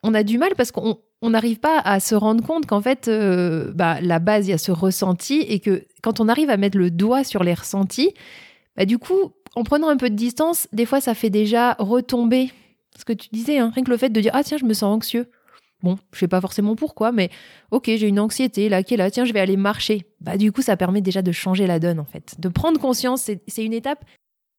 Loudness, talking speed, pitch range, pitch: -20 LUFS, 260 wpm, 195-245 Hz, 220 Hz